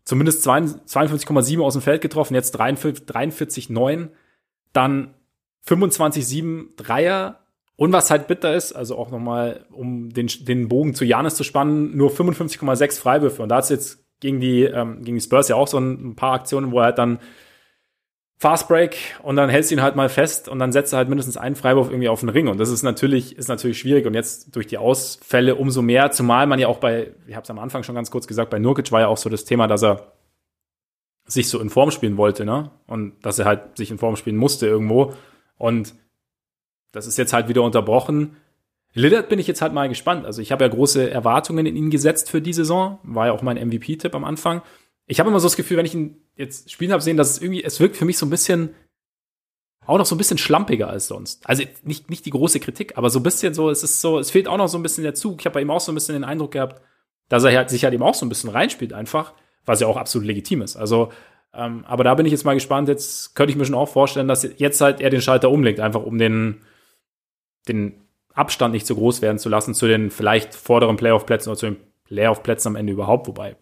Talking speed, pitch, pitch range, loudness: 235 wpm, 130 Hz, 115-150 Hz, -19 LUFS